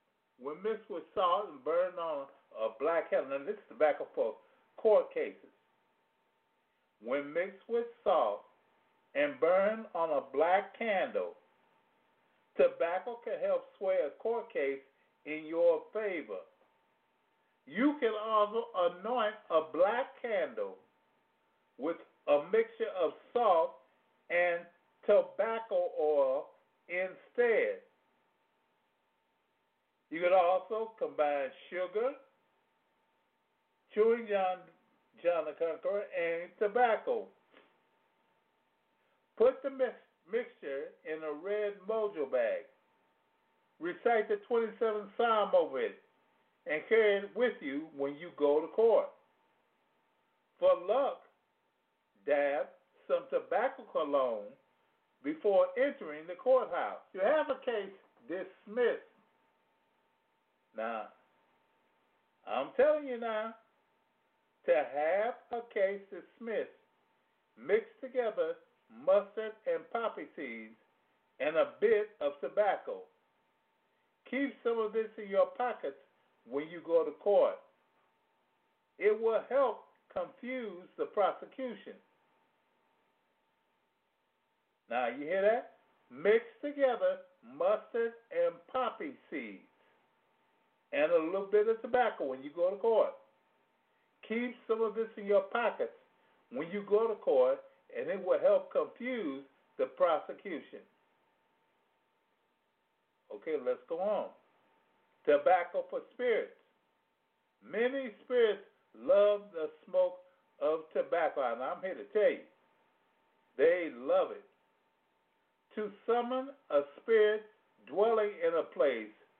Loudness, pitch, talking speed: -33 LUFS, 240 Hz, 110 wpm